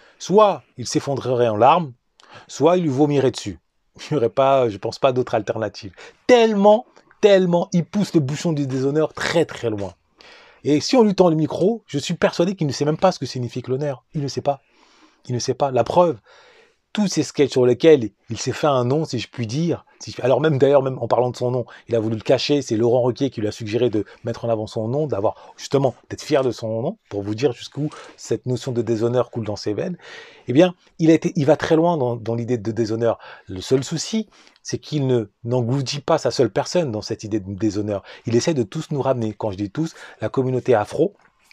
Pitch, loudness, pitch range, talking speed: 130 Hz, -20 LUFS, 115-160 Hz, 235 wpm